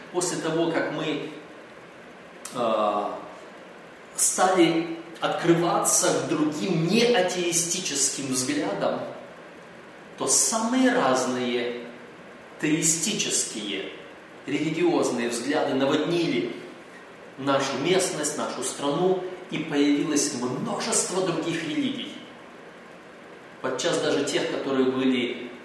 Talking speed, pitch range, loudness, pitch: 75 wpm, 140-185 Hz, -24 LUFS, 165 Hz